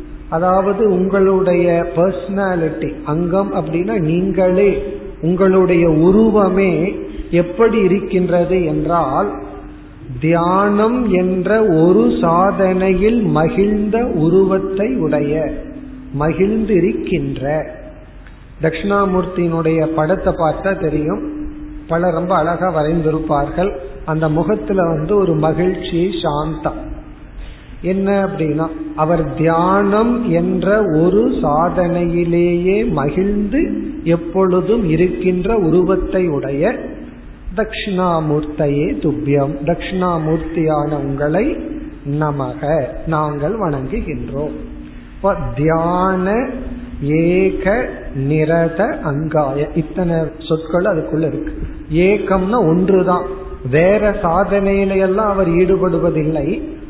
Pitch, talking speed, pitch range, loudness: 180 Hz, 70 wpm, 155-195 Hz, -16 LUFS